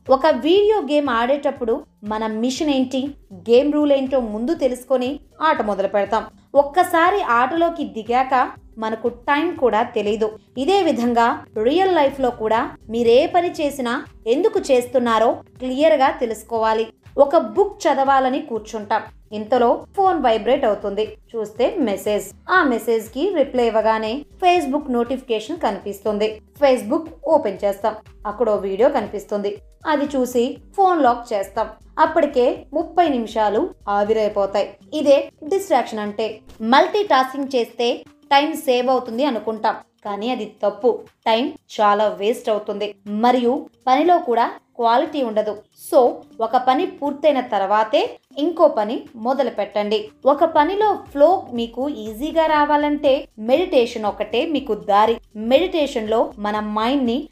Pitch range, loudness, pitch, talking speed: 220-295 Hz, -19 LUFS, 250 Hz, 120 wpm